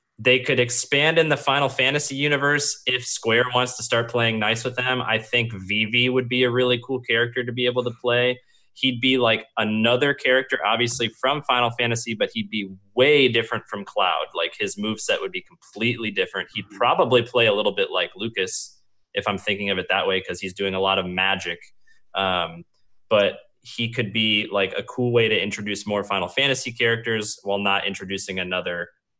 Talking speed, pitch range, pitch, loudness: 195 wpm, 105-130 Hz, 120 Hz, -22 LUFS